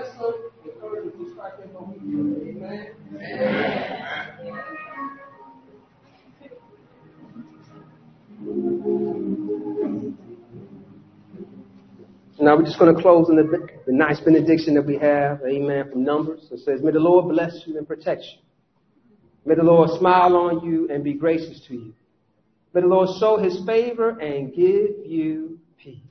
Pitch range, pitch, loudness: 140-200 Hz, 165 Hz, -20 LUFS